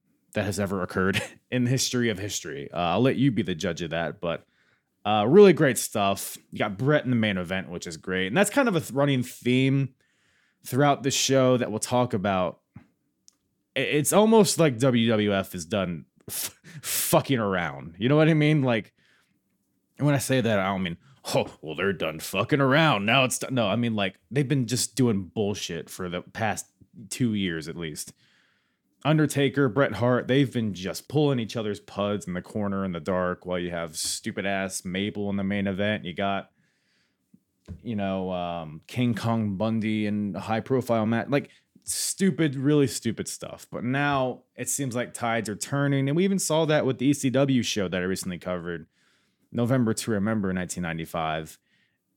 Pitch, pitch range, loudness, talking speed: 115 Hz, 95-135 Hz, -25 LUFS, 185 wpm